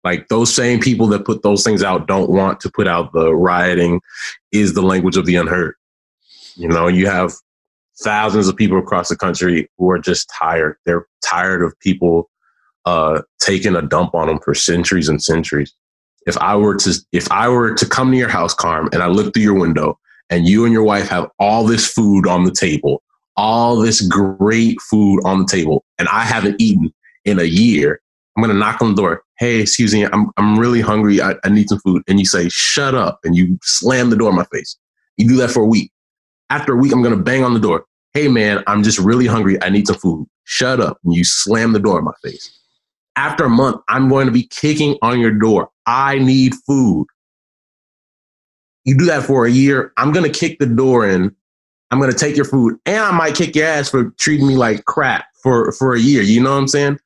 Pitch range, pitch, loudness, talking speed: 95-125 Hz, 105 Hz, -14 LUFS, 225 wpm